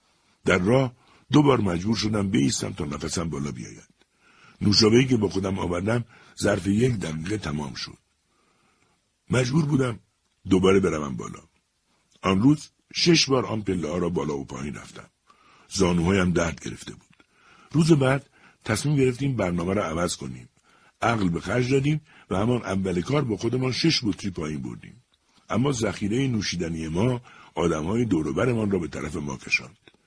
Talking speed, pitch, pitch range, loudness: 150 wpm, 100 Hz, 85-125 Hz, -24 LUFS